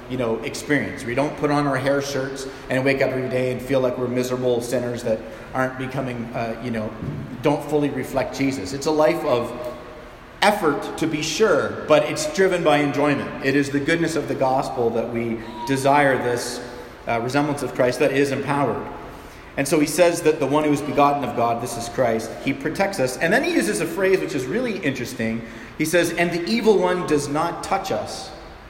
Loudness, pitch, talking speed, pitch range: -22 LUFS, 135 Hz, 210 wpm, 120-150 Hz